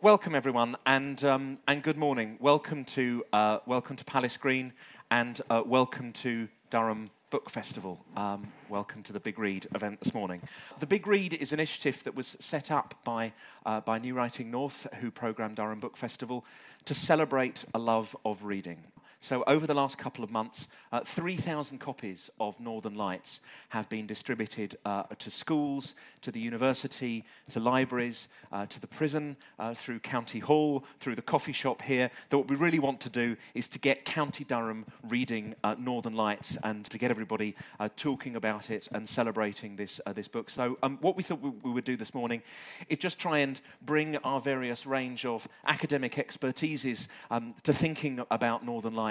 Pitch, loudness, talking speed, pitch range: 125 Hz, -32 LUFS, 185 wpm, 115-140 Hz